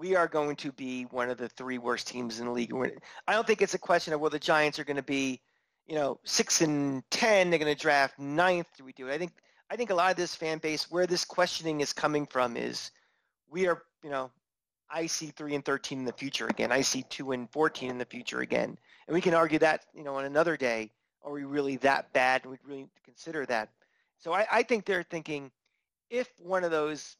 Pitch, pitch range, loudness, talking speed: 145 Hz, 130-165 Hz, -30 LUFS, 250 wpm